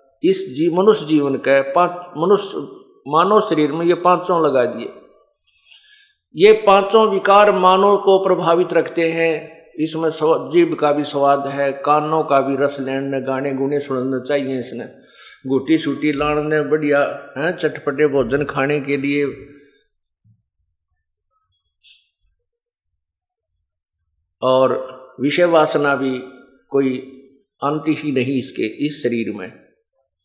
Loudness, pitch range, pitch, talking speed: -17 LUFS, 135-170 Hz, 145 Hz, 120 wpm